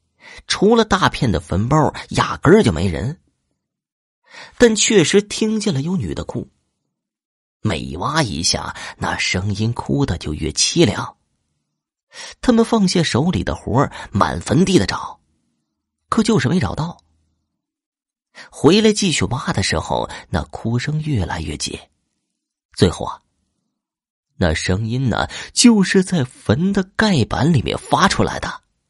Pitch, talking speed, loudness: 140 Hz, 190 characters per minute, -17 LUFS